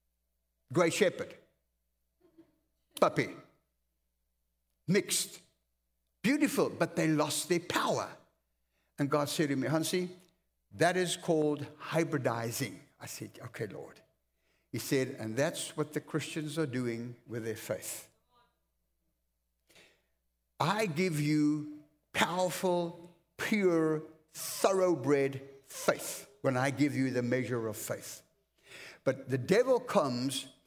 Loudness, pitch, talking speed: -32 LUFS, 135 Hz, 110 wpm